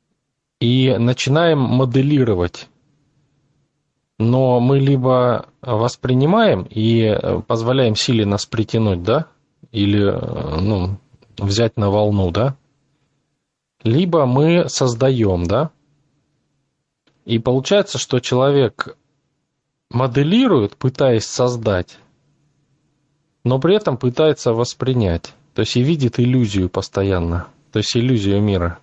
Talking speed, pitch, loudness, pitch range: 95 wpm, 130 Hz, -17 LUFS, 110-145 Hz